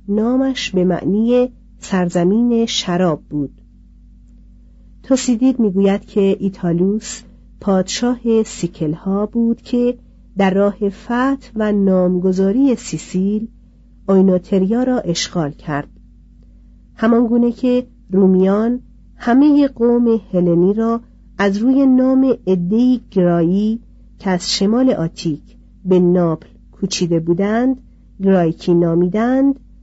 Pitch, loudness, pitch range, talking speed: 200 Hz, -16 LUFS, 180-235 Hz, 95 wpm